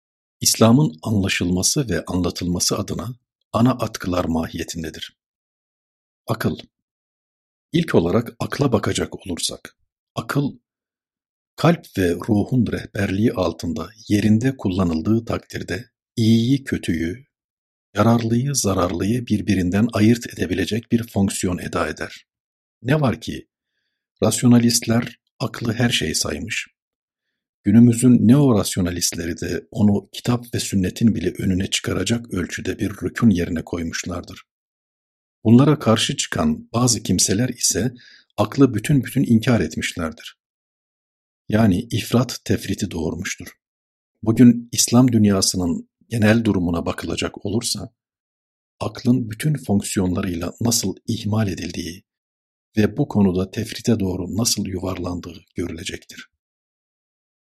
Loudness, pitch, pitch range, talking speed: -20 LUFS, 105 Hz, 90-120 Hz, 95 wpm